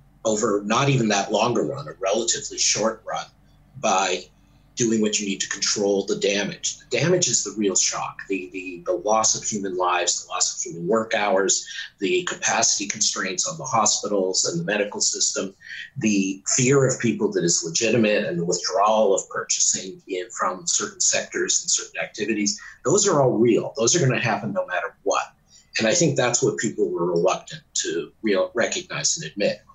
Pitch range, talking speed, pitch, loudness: 100-140 Hz, 190 wpm, 115 Hz, -22 LUFS